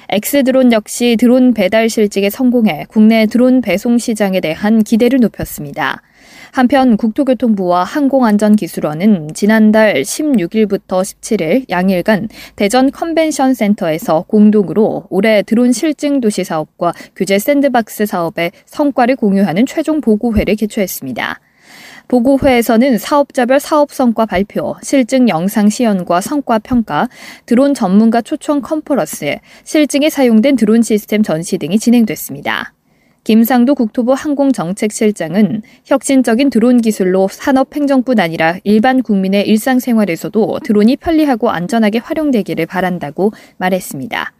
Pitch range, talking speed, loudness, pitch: 200-260 Hz, 325 characters per minute, -13 LUFS, 225 Hz